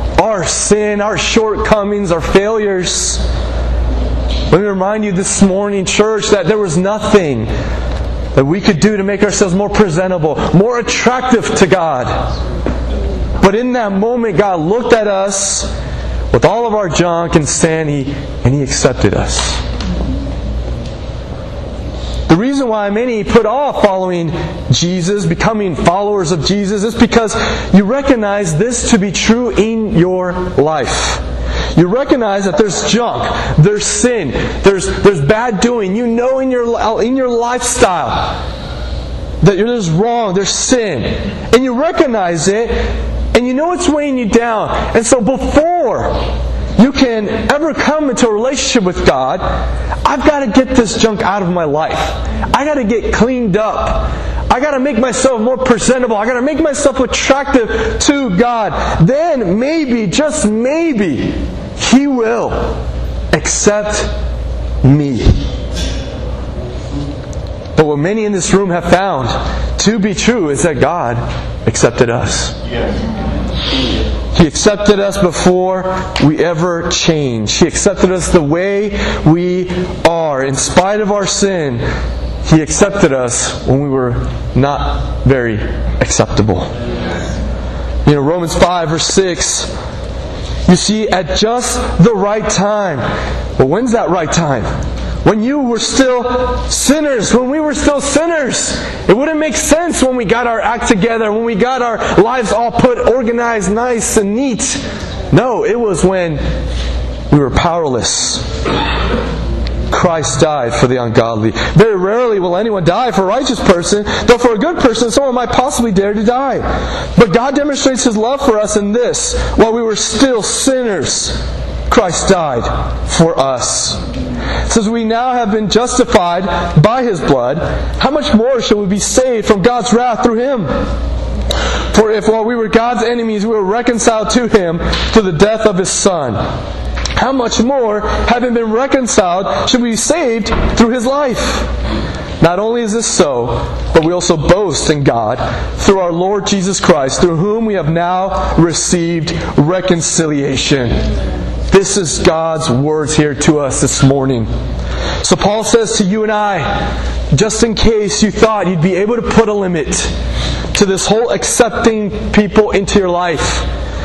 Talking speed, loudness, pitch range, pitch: 150 wpm, -13 LUFS, 165-235 Hz, 205 Hz